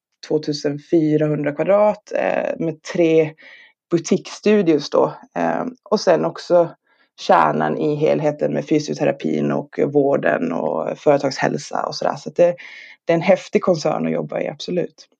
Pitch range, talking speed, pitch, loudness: 145-175 Hz, 140 wpm, 155 Hz, -19 LUFS